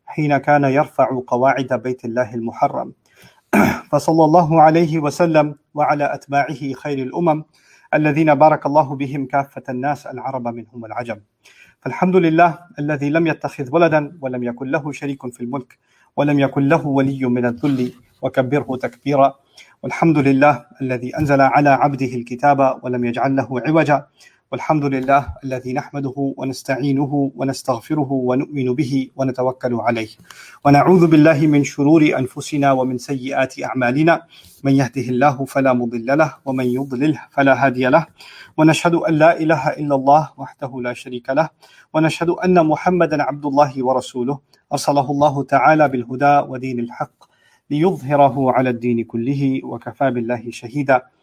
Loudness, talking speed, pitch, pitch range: -17 LUFS, 130 wpm, 140 Hz, 130-150 Hz